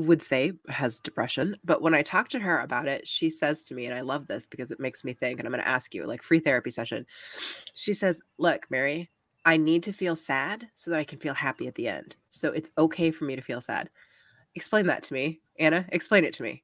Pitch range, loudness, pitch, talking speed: 145-175 Hz, -28 LUFS, 160 Hz, 255 wpm